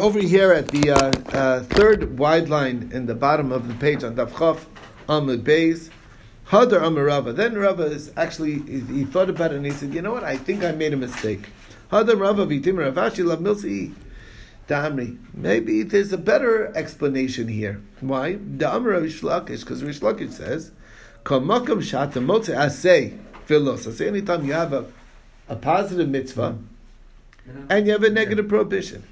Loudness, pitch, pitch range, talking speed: -21 LUFS, 150 Hz, 125-185 Hz, 160 wpm